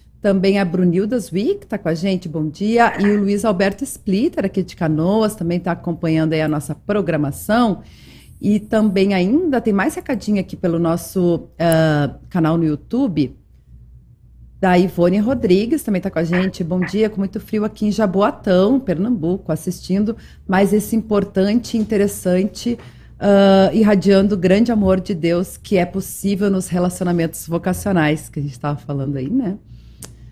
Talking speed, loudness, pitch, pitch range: 160 wpm, -18 LUFS, 190 Hz, 170-210 Hz